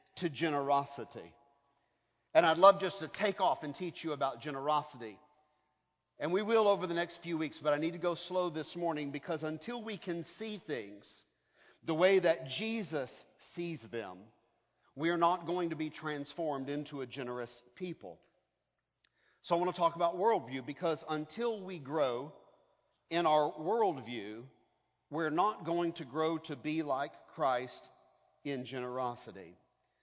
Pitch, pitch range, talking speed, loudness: 155 Hz, 140-175 Hz, 155 wpm, -34 LUFS